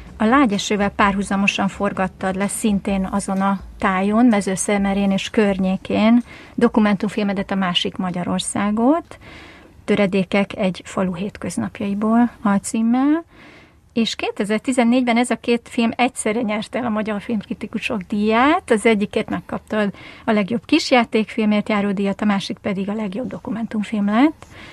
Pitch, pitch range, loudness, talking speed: 215 Hz, 200-235 Hz, -19 LUFS, 120 wpm